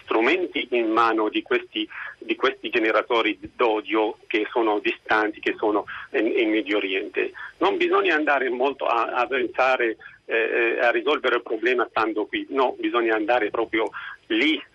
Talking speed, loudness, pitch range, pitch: 150 wpm, -23 LUFS, 330-385 Hz, 360 Hz